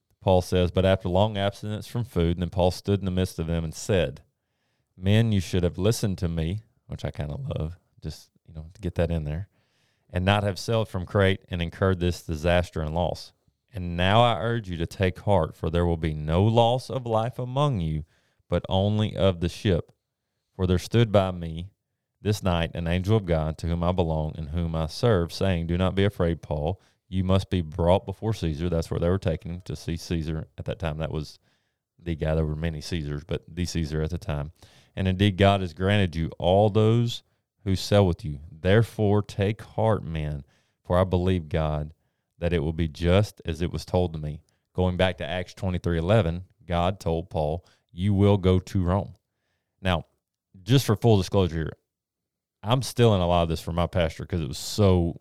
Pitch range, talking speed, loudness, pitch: 85-105 Hz, 215 wpm, -26 LUFS, 90 Hz